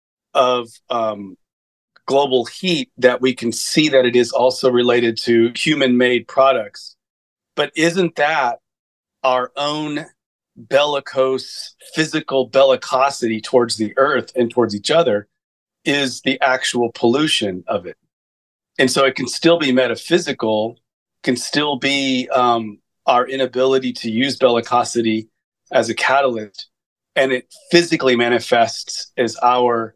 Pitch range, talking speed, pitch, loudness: 120-140 Hz, 125 wpm, 130 Hz, -17 LUFS